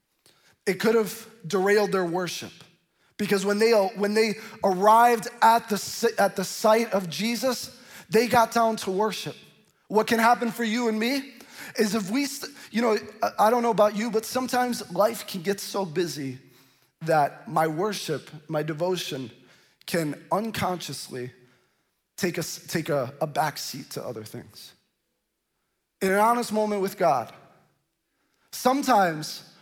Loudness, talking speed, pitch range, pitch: -25 LUFS, 145 wpm, 175-230 Hz, 205 Hz